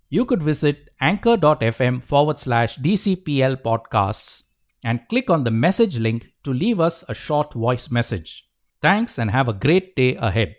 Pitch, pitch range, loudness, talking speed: 135 Hz, 115-165 Hz, -20 LUFS, 160 wpm